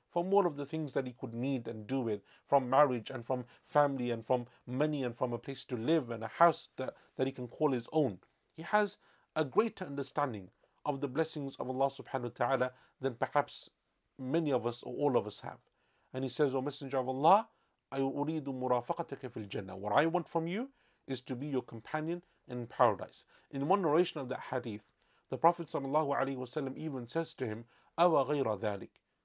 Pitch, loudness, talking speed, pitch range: 135 Hz, -34 LUFS, 190 wpm, 125-155 Hz